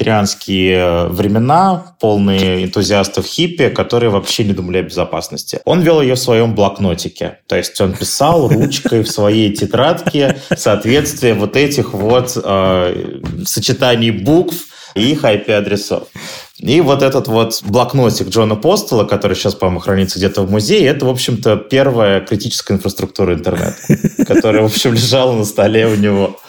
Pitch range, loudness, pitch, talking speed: 100-125 Hz, -13 LUFS, 110 Hz, 145 wpm